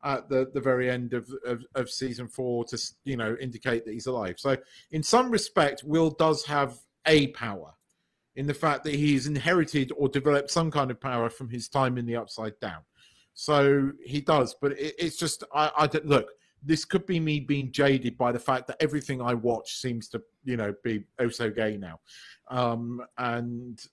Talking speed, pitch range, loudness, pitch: 200 wpm, 120-145 Hz, -28 LUFS, 135 Hz